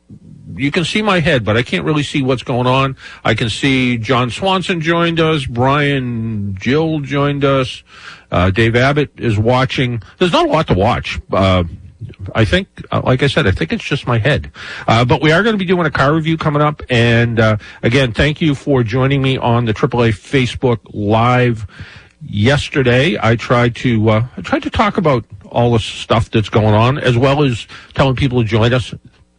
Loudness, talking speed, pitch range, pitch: -14 LUFS, 200 wpm, 115-145 Hz, 125 Hz